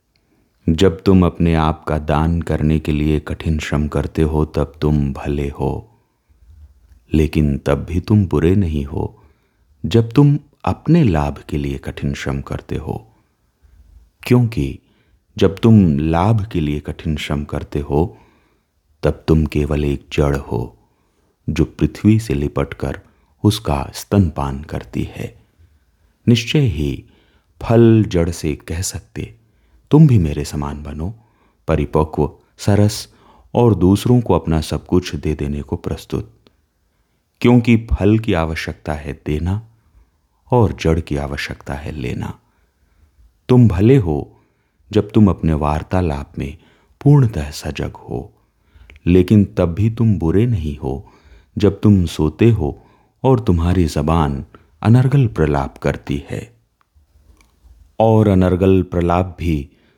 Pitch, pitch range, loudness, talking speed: 80 Hz, 75-105 Hz, -17 LUFS, 125 wpm